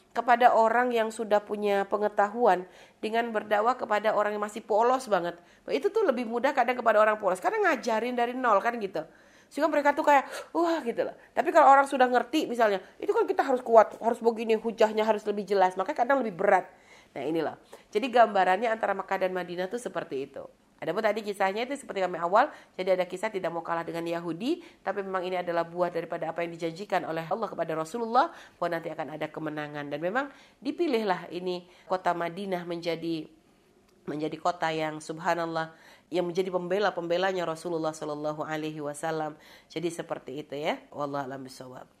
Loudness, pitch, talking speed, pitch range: -28 LUFS, 190 Hz, 180 wpm, 170-235 Hz